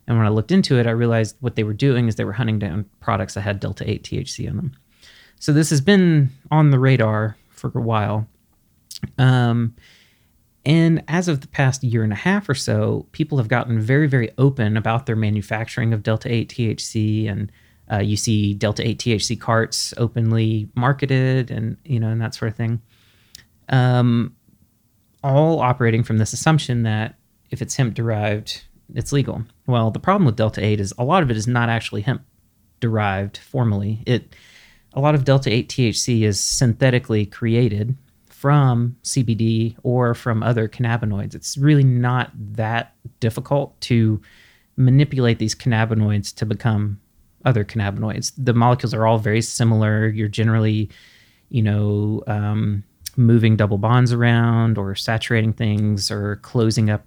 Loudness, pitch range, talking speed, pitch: -20 LUFS, 110-125 Hz, 165 wpm, 115 Hz